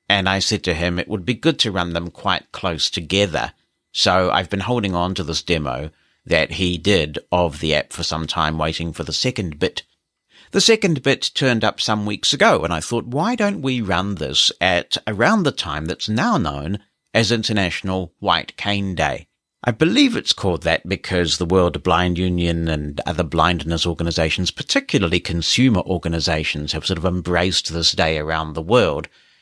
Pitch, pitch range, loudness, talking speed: 90 Hz, 85-105 Hz, -19 LUFS, 185 wpm